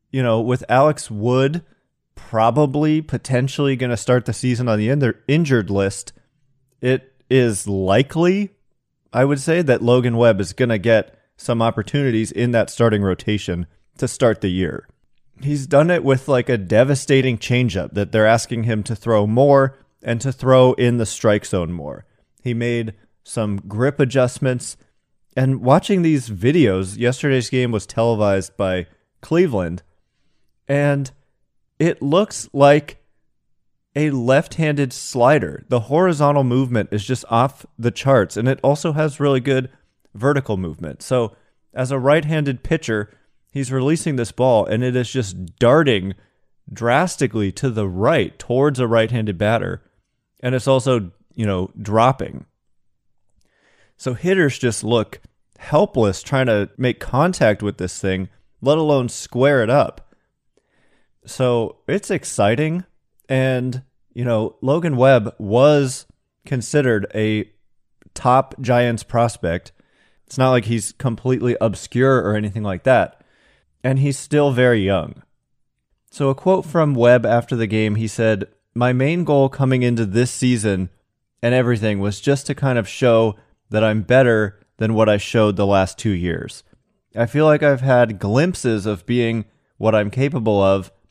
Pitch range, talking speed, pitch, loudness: 110-135 Hz, 150 wpm, 125 Hz, -18 LUFS